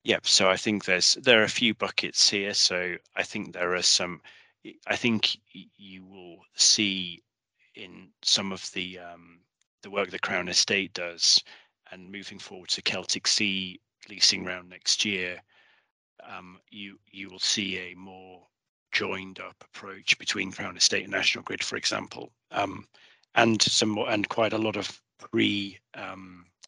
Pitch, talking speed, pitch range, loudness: 95 Hz, 160 wpm, 90-100 Hz, -25 LUFS